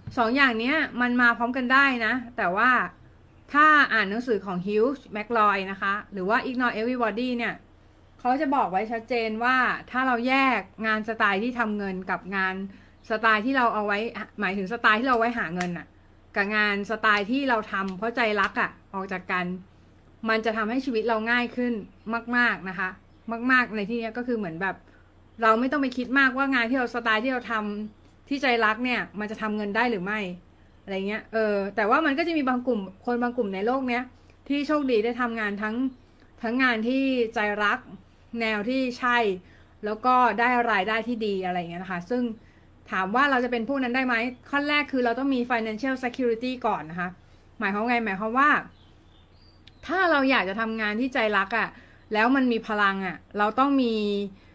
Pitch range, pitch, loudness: 210-250 Hz, 230 Hz, -25 LUFS